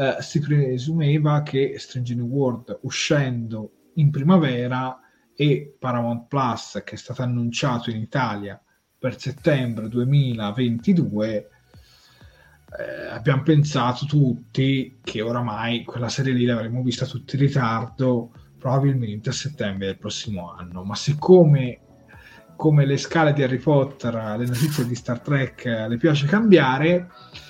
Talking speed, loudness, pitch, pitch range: 125 wpm, -22 LUFS, 130 Hz, 115-145 Hz